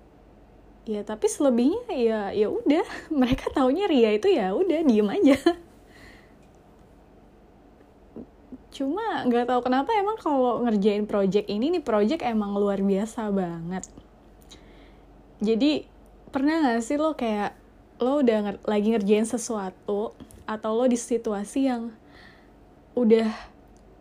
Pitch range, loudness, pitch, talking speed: 210-285 Hz, -24 LUFS, 235 Hz, 115 wpm